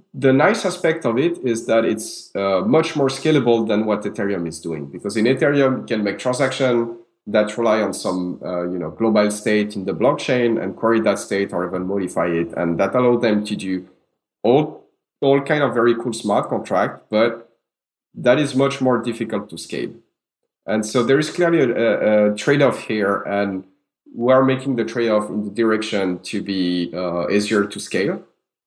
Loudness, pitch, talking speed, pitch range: -19 LUFS, 110 Hz, 190 wpm, 100-125 Hz